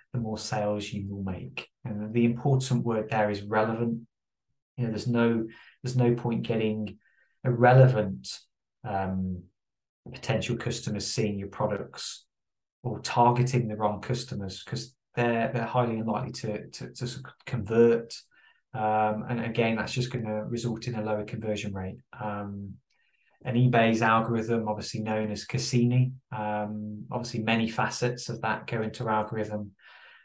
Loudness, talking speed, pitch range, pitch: -28 LUFS, 145 wpm, 105-125 Hz, 115 Hz